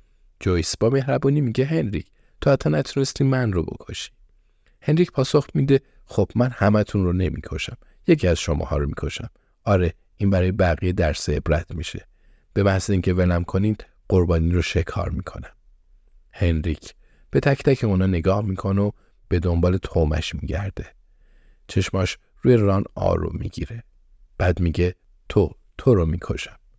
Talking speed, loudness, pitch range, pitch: 140 wpm, -22 LUFS, 85-105 Hz, 95 Hz